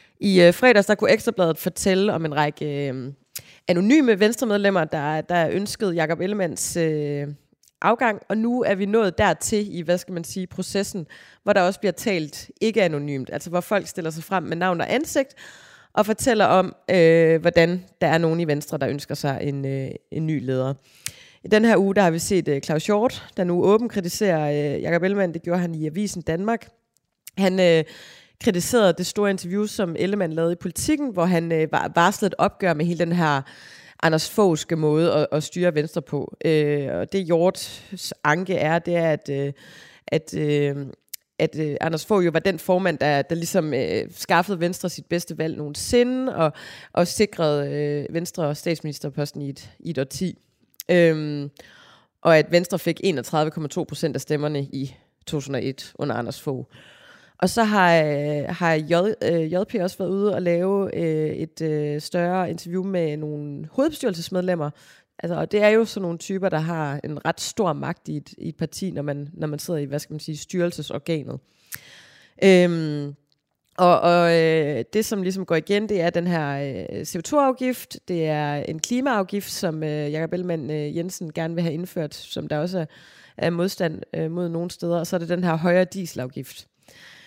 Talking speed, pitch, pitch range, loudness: 180 wpm, 170 Hz, 150-190 Hz, -22 LUFS